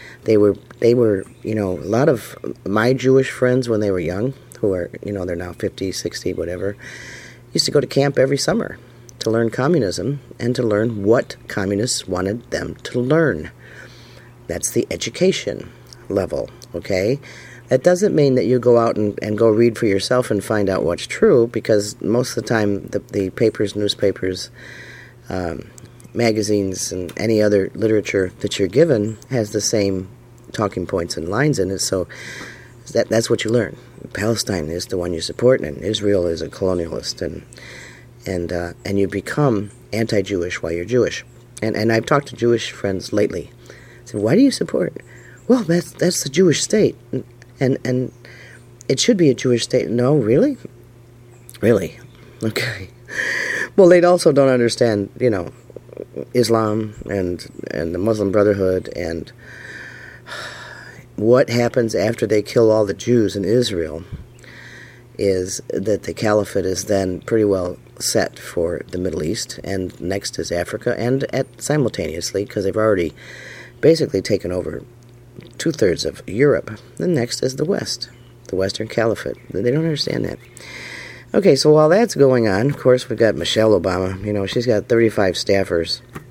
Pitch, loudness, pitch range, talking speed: 115 Hz, -19 LUFS, 100-125 Hz, 165 wpm